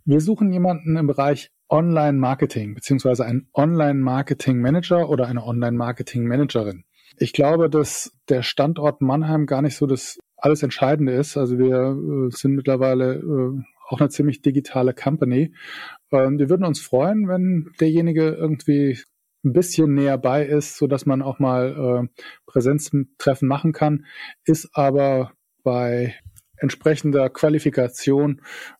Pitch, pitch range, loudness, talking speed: 140 Hz, 130-150 Hz, -20 LUFS, 135 wpm